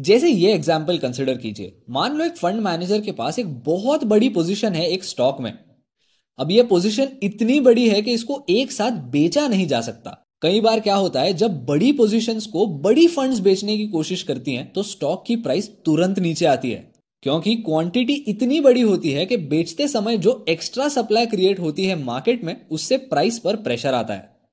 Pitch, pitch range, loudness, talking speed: 205 Hz, 170-240 Hz, -20 LUFS, 200 wpm